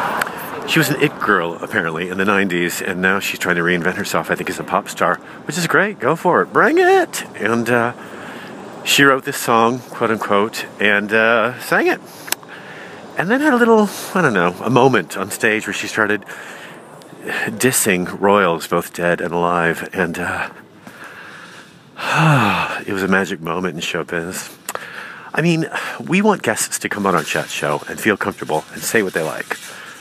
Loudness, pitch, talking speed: -17 LUFS, 110 Hz, 180 wpm